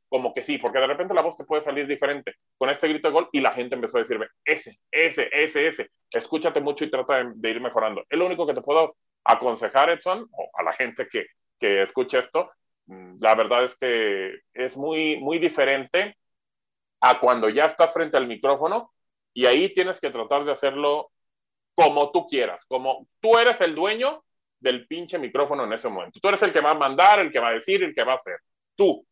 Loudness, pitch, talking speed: -23 LUFS, 175 Hz, 210 wpm